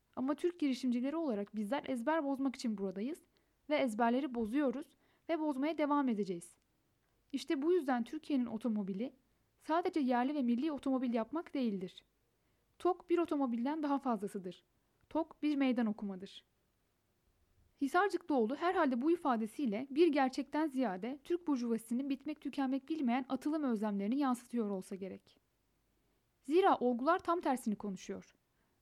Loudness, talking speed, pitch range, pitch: -36 LUFS, 125 wpm, 230-305 Hz, 265 Hz